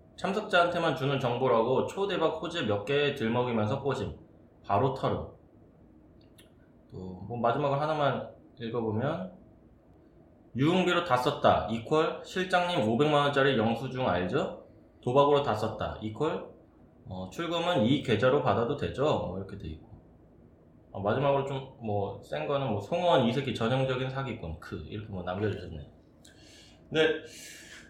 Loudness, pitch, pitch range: -29 LUFS, 120 Hz, 100-145 Hz